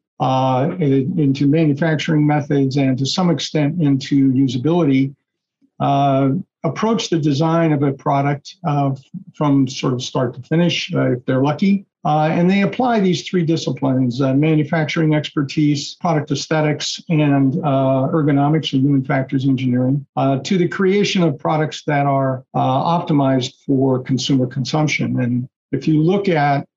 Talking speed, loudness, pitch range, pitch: 145 wpm, -17 LUFS, 135-165 Hz, 145 Hz